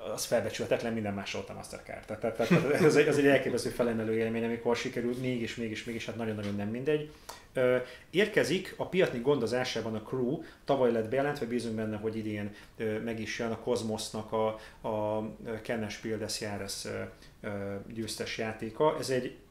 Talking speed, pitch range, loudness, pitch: 160 wpm, 110-125 Hz, -32 LUFS, 115 Hz